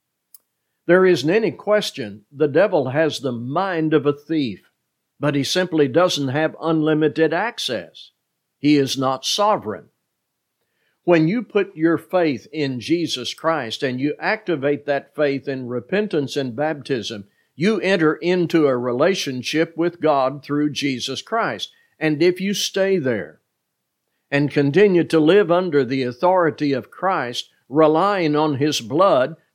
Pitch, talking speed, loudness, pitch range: 155 Hz, 140 wpm, -20 LUFS, 140-170 Hz